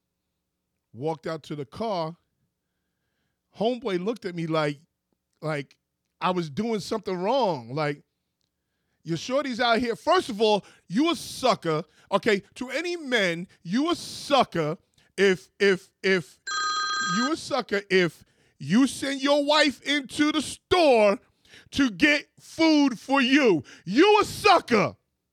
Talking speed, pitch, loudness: 135 wpm, 210 Hz, -24 LUFS